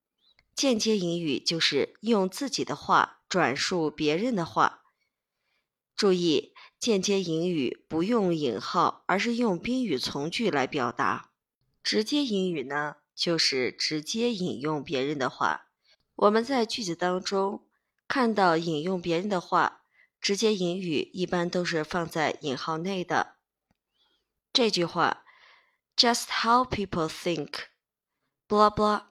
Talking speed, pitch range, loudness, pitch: 225 characters per minute, 165-220 Hz, -27 LUFS, 185 Hz